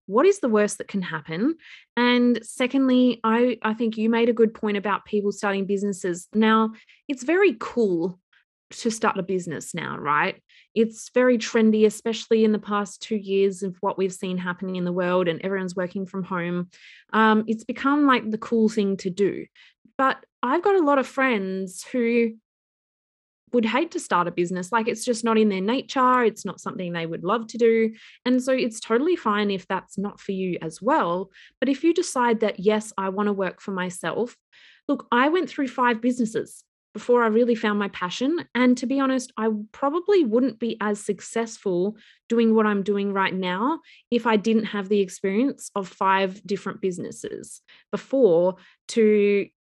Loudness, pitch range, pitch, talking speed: -23 LUFS, 195-245 Hz, 220 Hz, 185 wpm